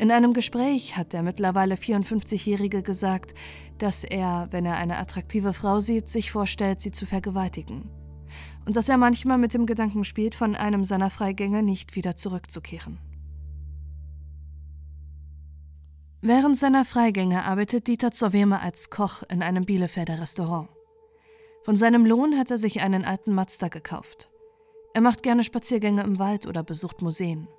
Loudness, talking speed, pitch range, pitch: -24 LUFS, 145 wpm, 170-230 Hz, 195 Hz